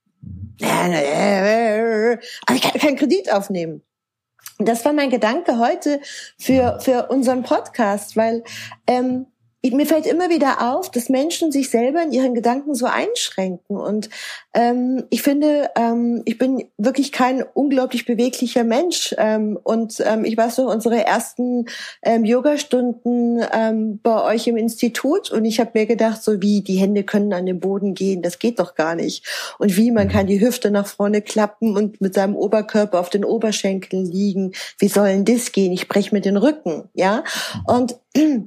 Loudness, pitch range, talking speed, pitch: -19 LUFS, 205-255 Hz, 165 wpm, 230 Hz